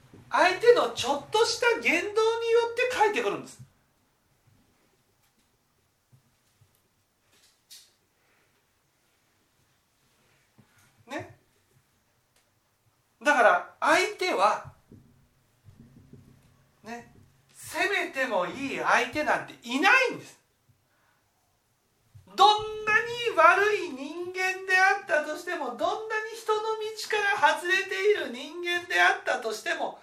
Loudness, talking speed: -25 LUFS, 180 characters per minute